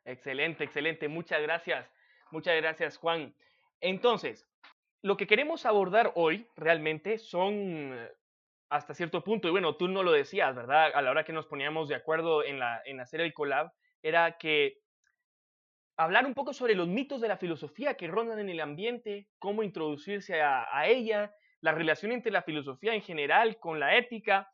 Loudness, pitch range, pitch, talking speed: -30 LUFS, 155-220 Hz, 180 Hz, 170 wpm